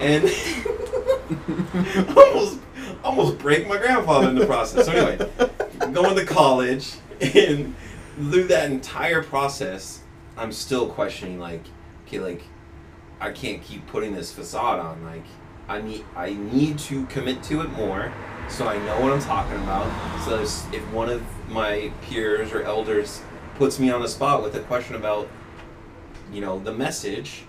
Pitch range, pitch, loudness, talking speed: 95-150 Hz, 115 Hz, -22 LUFS, 155 wpm